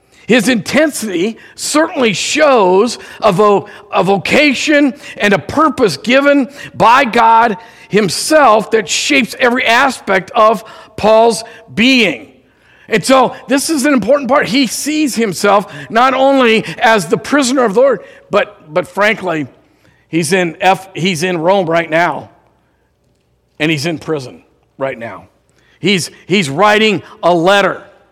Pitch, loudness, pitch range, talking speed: 220 Hz, -12 LUFS, 190-260 Hz, 130 wpm